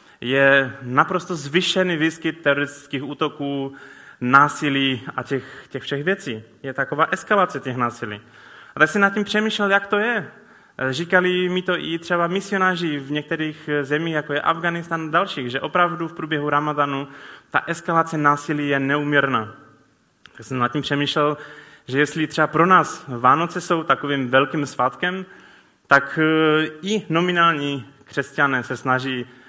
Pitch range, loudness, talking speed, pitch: 135-170 Hz, -20 LUFS, 145 wpm, 150 Hz